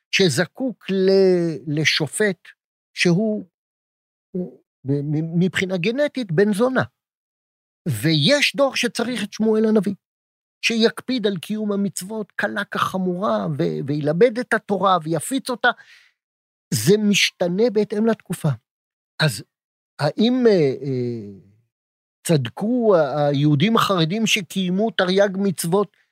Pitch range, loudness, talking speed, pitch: 160-220 Hz, -20 LUFS, 90 wpm, 195 Hz